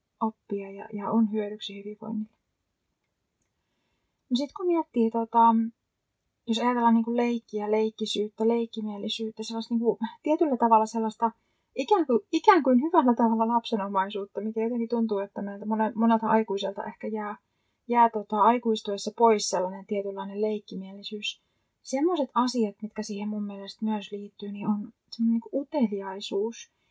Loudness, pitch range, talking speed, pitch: -27 LUFS, 210-230 Hz, 135 wpm, 220 Hz